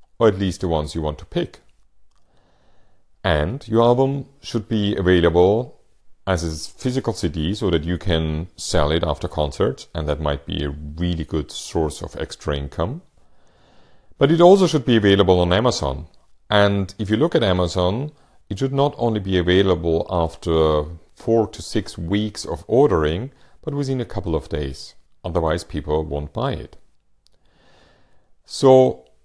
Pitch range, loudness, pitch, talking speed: 80-110 Hz, -20 LUFS, 90 Hz, 160 wpm